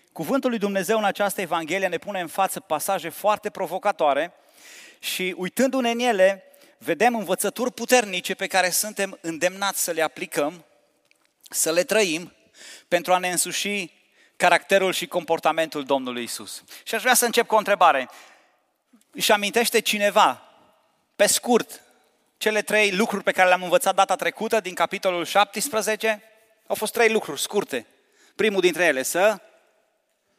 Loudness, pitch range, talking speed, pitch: -22 LUFS, 180-215 Hz, 145 wpm, 195 Hz